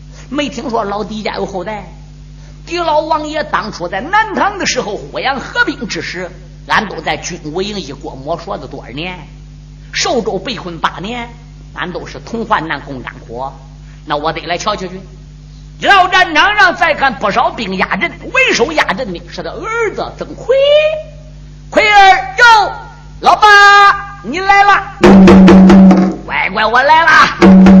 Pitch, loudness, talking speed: 190 Hz, -10 LUFS, 210 characters per minute